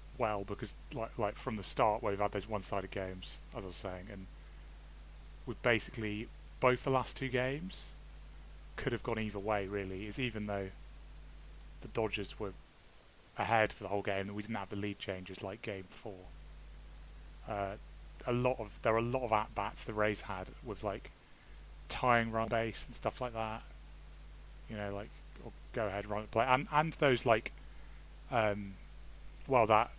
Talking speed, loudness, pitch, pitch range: 180 wpm, -36 LUFS, 105 Hz, 95-115 Hz